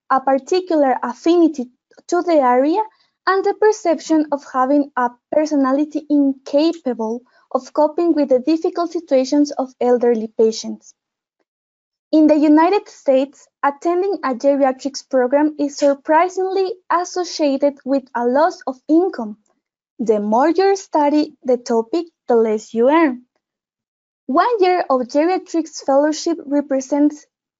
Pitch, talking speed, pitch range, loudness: 290 Hz, 120 wpm, 260-335 Hz, -17 LUFS